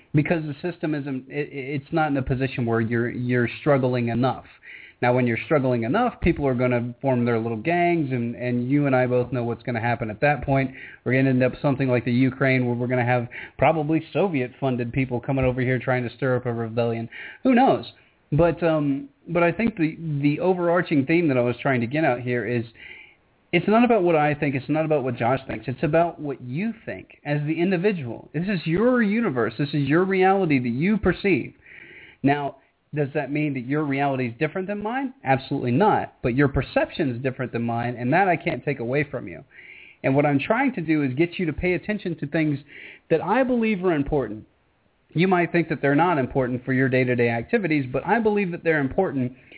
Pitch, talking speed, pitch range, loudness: 140 Hz, 230 wpm, 125-165 Hz, -23 LUFS